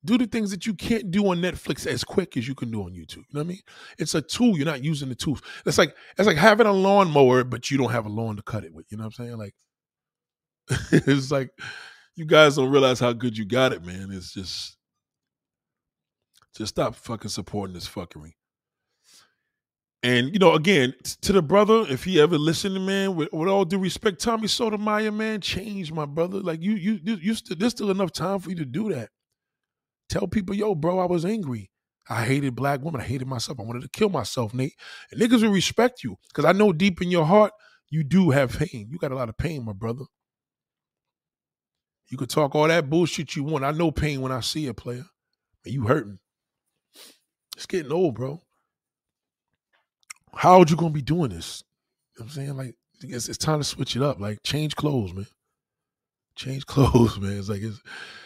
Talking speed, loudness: 215 wpm, -23 LUFS